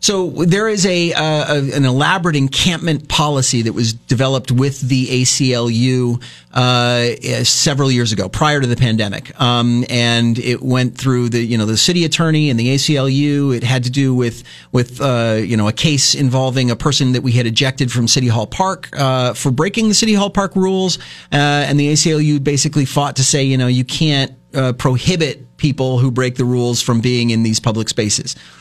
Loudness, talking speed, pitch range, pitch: -15 LUFS, 195 wpm, 120-150 Hz, 130 Hz